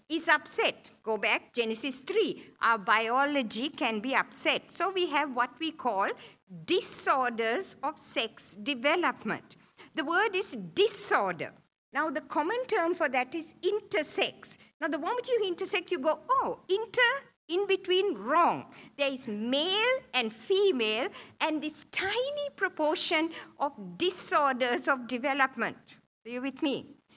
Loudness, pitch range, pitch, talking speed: -30 LUFS, 255-370 Hz, 305 Hz, 135 wpm